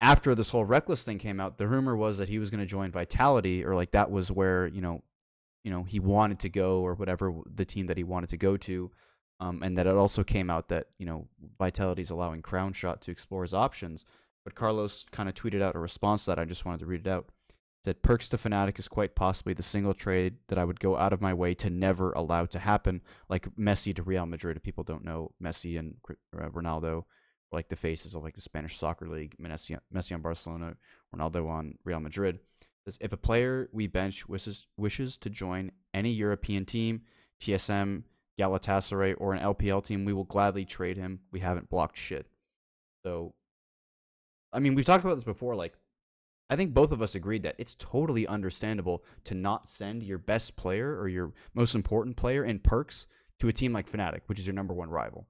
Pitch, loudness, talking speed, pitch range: 95 Hz, -31 LUFS, 215 wpm, 90-105 Hz